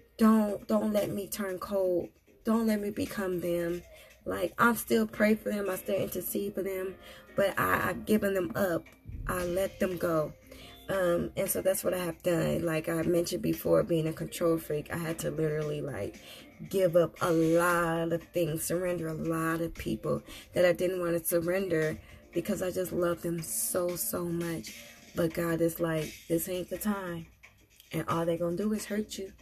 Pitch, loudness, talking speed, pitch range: 175 Hz, -31 LUFS, 195 wpm, 165-190 Hz